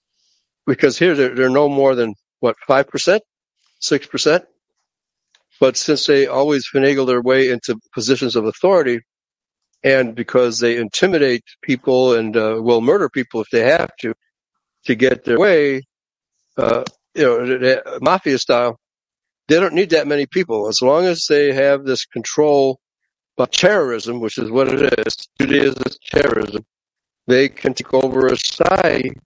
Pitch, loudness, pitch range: 130 Hz, -16 LUFS, 120-140 Hz